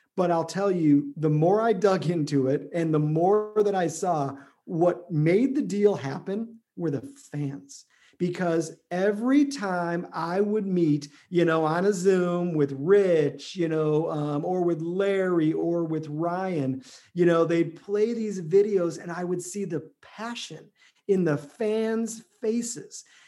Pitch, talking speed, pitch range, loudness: 175 Hz, 160 wpm, 155-200 Hz, -26 LUFS